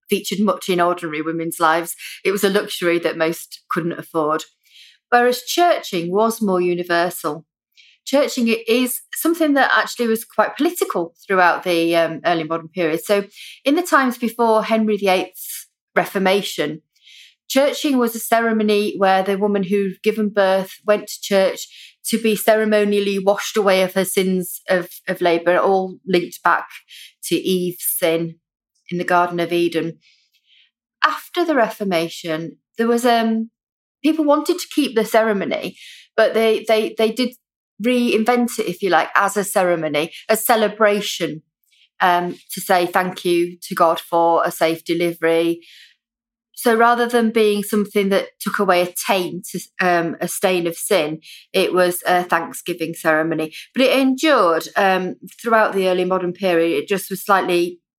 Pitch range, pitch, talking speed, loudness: 170-225 Hz, 190 Hz, 150 wpm, -18 LUFS